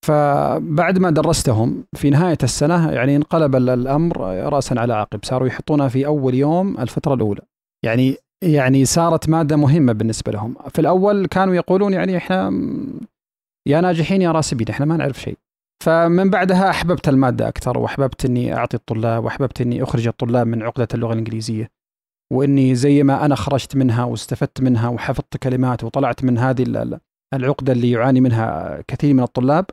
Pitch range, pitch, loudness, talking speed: 125-160 Hz, 135 Hz, -18 LUFS, 155 wpm